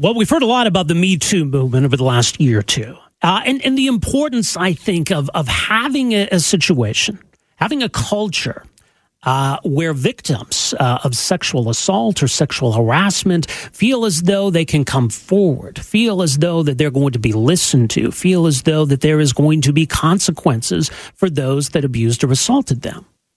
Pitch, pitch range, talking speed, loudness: 160 Hz, 135-195 Hz, 195 wpm, -15 LUFS